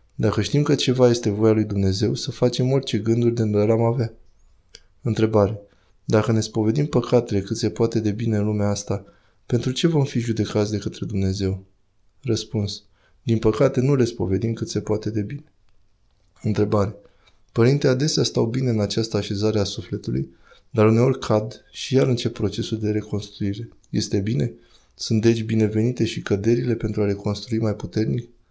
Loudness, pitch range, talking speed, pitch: -22 LUFS, 105-115 Hz, 165 wpm, 110 Hz